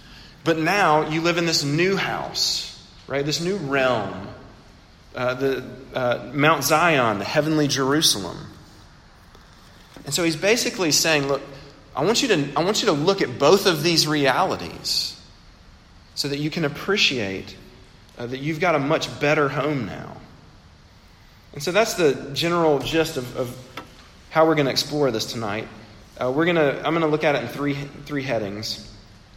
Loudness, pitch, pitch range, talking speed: -21 LUFS, 140 Hz, 115-160 Hz, 165 wpm